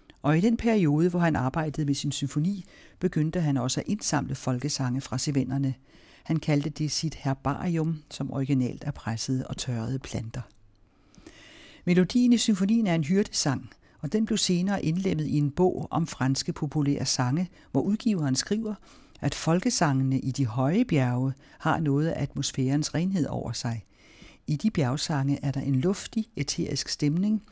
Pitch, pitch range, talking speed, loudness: 145 Hz, 135-175 Hz, 160 wpm, -27 LUFS